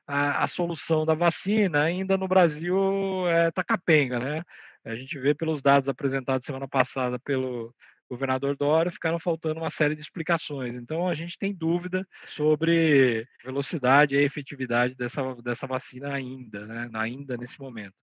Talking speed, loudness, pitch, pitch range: 145 wpm, -26 LUFS, 145 Hz, 130-170 Hz